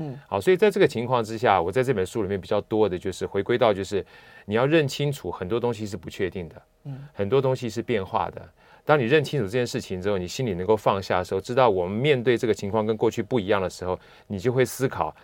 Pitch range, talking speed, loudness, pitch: 105-135 Hz, 375 characters per minute, -24 LUFS, 115 Hz